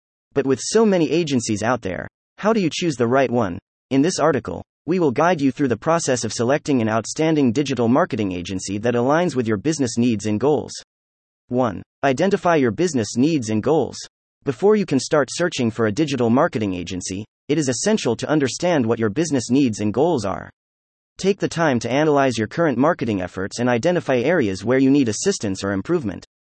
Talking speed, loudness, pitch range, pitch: 195 wpm, -20 LUFS, 105-150 Hz, 125 Hz